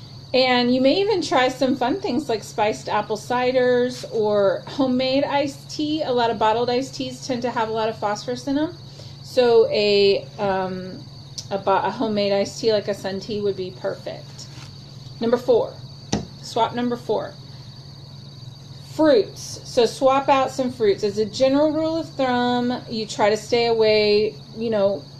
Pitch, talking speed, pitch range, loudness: 225 Hz, 165 wpm, 195-260 Hz, -21 LUFS